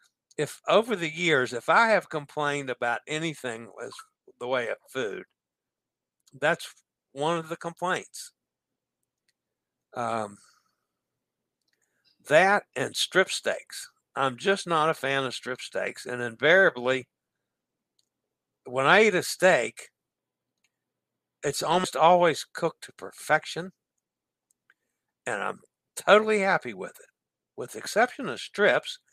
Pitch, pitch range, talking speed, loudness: 155 Hz, 125-195 Hz, 115 wpm, -25 LUFS